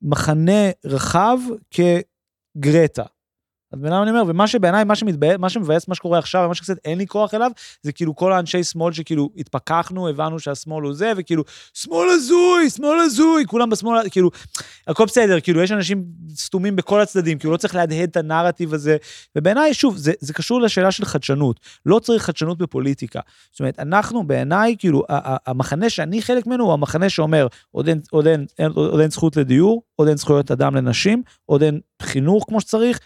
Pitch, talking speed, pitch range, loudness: 175 Hz, 160 wpm, 155-210 Hz, -18 LUFS